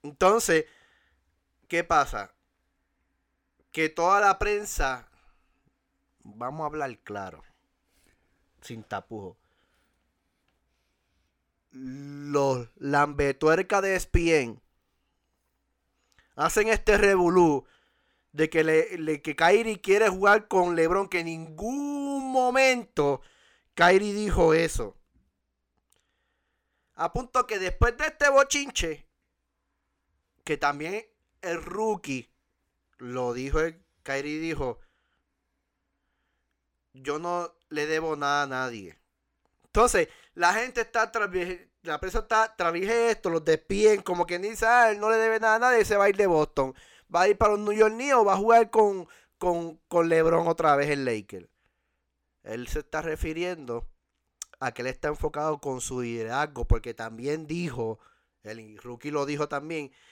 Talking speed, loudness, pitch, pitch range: 125 wpm, -25 LUFS, 160 Hz, 120-200 Hz